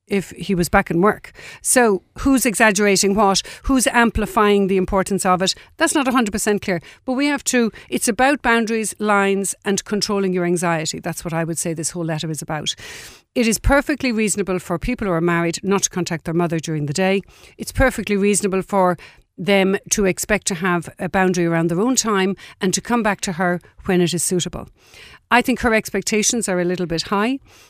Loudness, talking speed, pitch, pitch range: -19 LUFS, 200 wpm, 195 Hz, 180-220 Hz